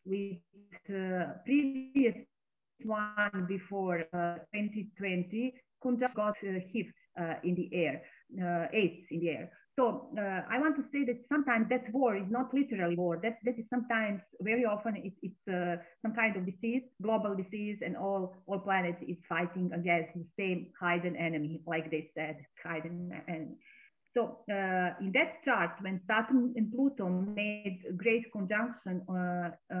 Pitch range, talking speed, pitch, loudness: 175-230 Hz, 160 wpm, 195 Hz, -34 LUFS